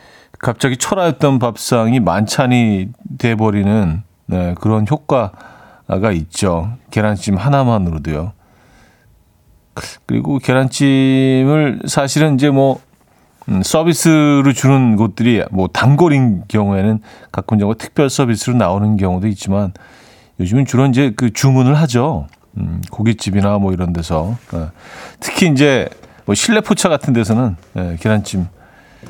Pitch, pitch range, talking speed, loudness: 110 Hz, 95-135 Hz, 265 characters per minute, -14 LUFS